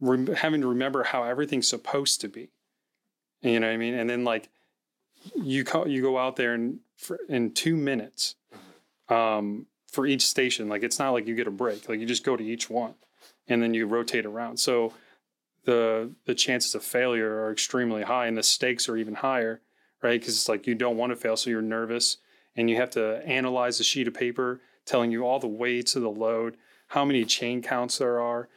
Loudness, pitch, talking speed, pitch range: -26 LUFS, 120 Hz, 210 wpm, 115-125 Hz